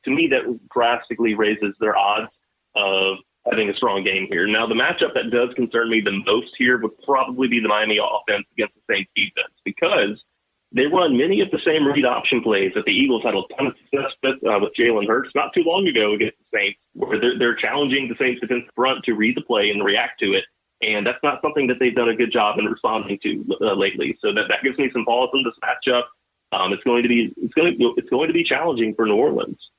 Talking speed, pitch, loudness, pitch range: 240 wpm, 120 Hz, -20 LUFS, 110-135 Hz